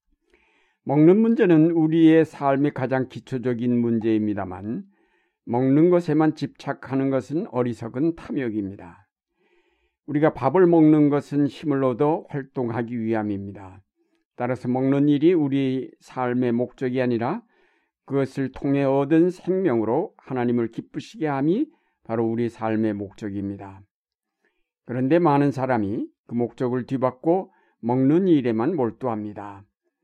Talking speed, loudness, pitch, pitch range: 275 characters per minute, -22 LUFS, 130 Hz, 120-155 Hz